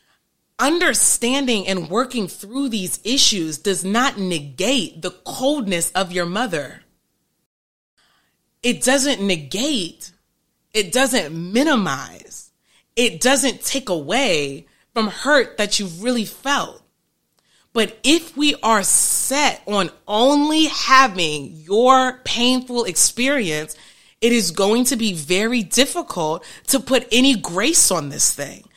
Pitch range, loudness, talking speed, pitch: 190-265 Hz, -18 LUFS, 115 wpm, 235 Hz